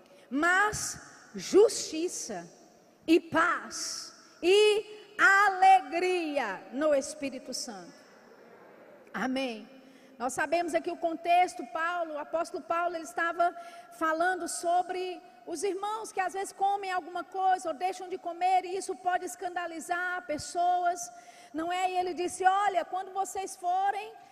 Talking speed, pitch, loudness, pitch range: 120 wpm, 350 Hz, -29 LUFS, 330-370 Hz